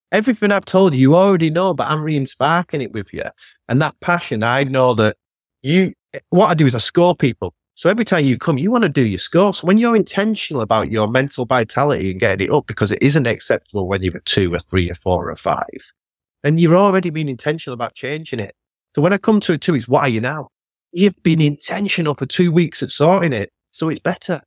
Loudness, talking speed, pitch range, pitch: -17 LUFS, 240 wpm, 125-180 Hz, 150 Hz